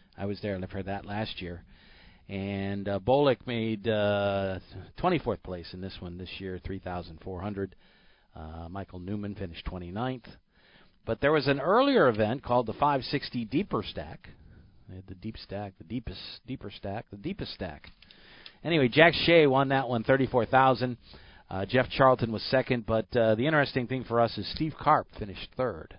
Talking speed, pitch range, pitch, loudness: 165 wpm, 95-130 Hz, 110 Hz, -28 LUFS